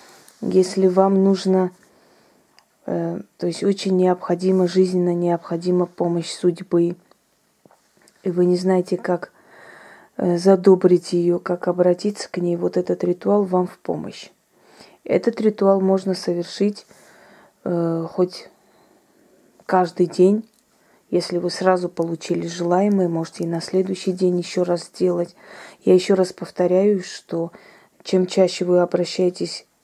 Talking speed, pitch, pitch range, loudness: 120 wpm, 180 Hz, 175-190 Hz, -20 LUFS